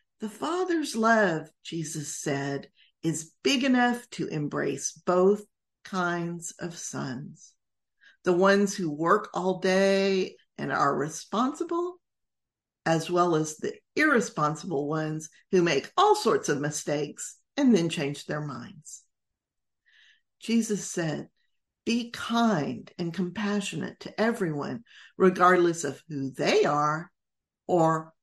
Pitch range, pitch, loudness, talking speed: 155-210 Hz, 180 Hz, -27 LUFS, 115 wpm